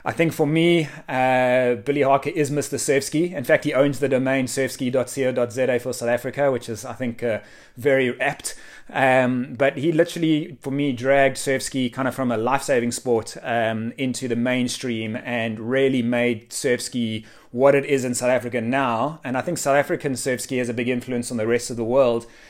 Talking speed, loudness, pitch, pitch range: 195 wpm, -22 LUFS, 130 Hz, 120-140 Hz